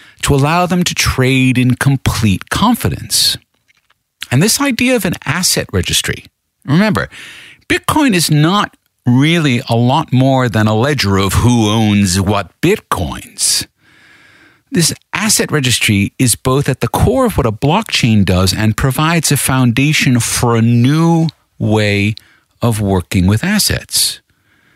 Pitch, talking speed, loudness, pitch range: 125 Hz, 135 wpm, -13 LUFS, 110-155 Hz